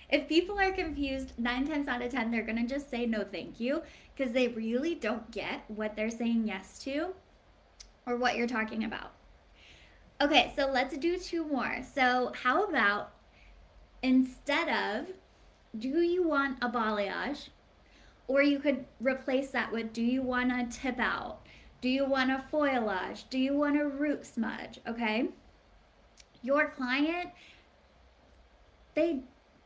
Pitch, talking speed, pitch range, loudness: 260 Hz, 150 wpm, 230-290 Hz, -31 LUFS